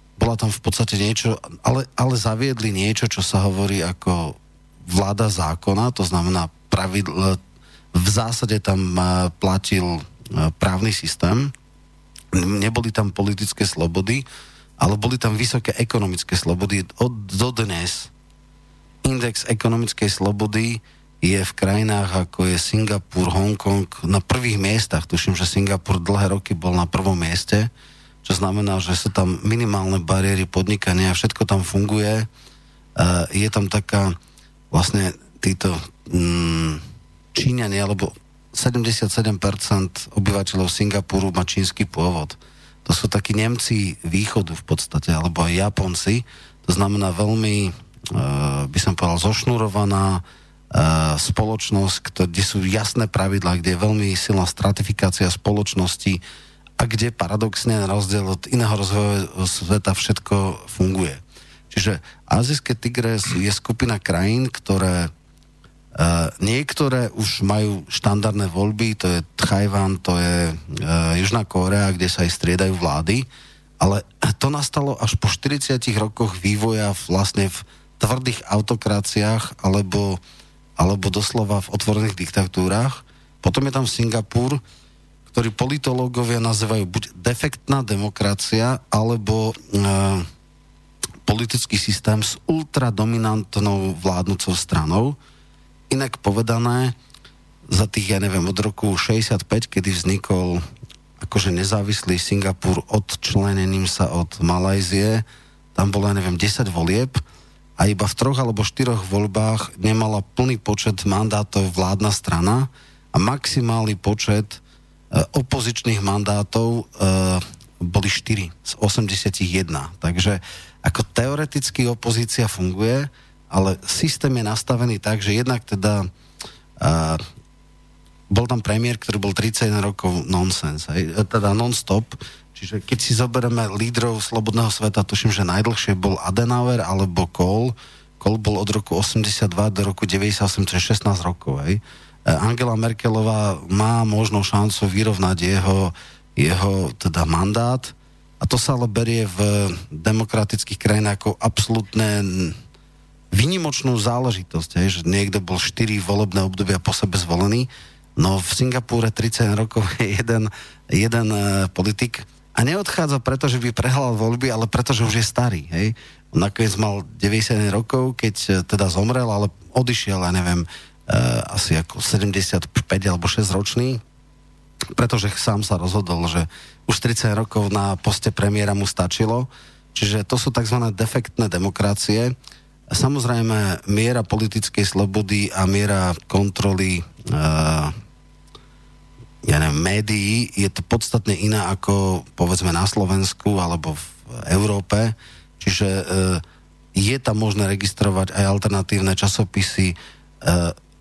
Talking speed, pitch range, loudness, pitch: 120 wpm, 95-115 Hz, -20 LUFS, 100 Hz